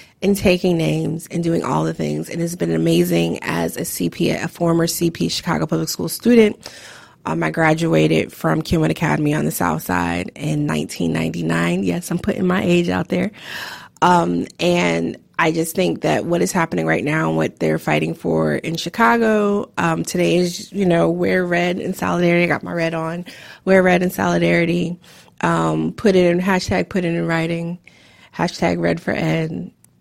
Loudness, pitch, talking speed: -19 LUFS, 165 Hz, 180 wpm